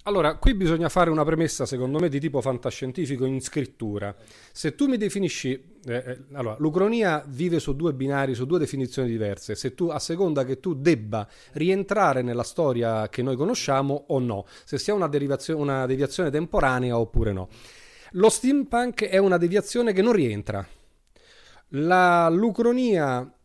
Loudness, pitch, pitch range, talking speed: -24 LUFS, 140 Hz, 125-180 Hz, 160 wpm